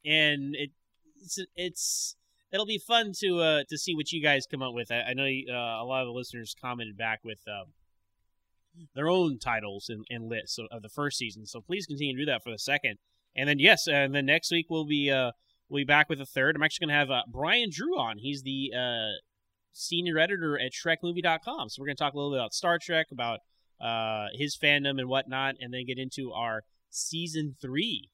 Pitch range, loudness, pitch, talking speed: 115-160 Hz, -29 LUFS, 140 Hz, 220 wpm